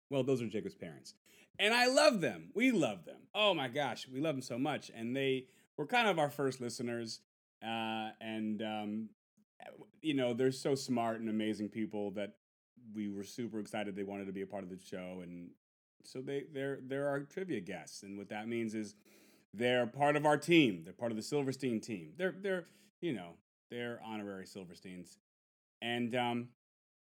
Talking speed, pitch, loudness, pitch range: 190 wpm, 120 Hz, -36 LUFS, 105-140 Hz